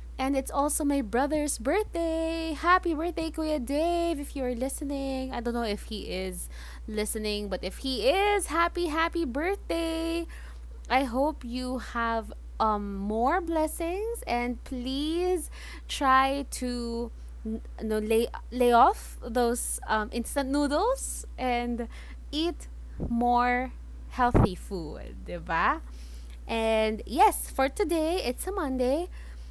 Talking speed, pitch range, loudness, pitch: 120 wpm, 230-325 Hz, -28 LUFS, 265 Hz